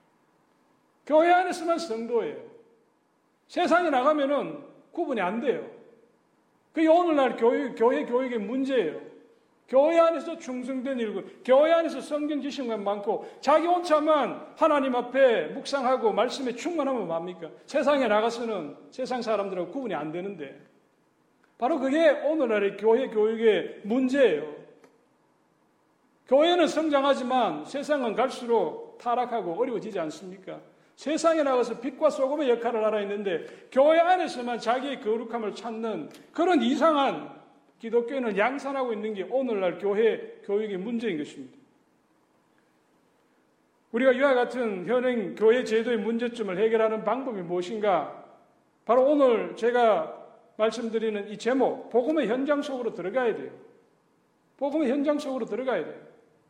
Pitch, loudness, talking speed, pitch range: 255 Hz, -26 LUFS, 305 characters per minute, 225-300 Hz